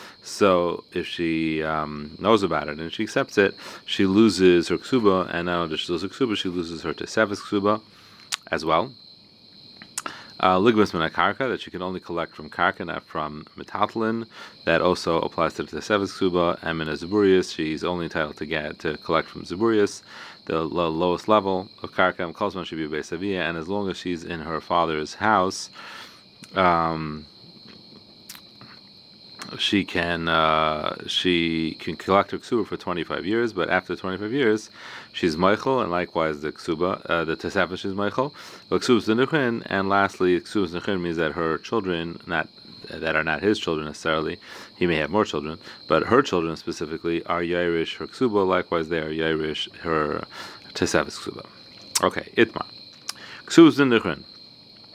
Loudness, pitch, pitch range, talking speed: -24 LUFS, 90 Hz, 85-105 Hz, 155 wpm